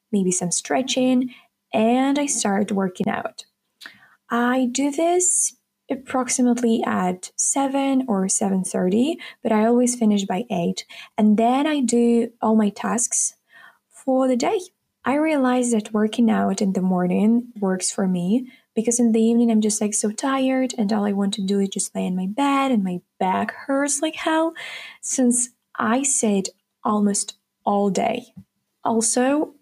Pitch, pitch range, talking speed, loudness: 235 Hz, 205-260 Hz, 160 wpm, -21 LUFS